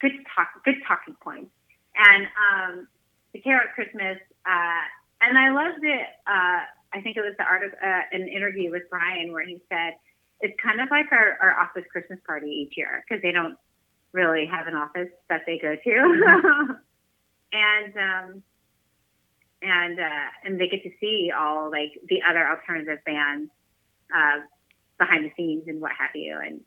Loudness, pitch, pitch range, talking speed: -22 LUFS, 180 Hz, 165-210 Hz, 175 wpm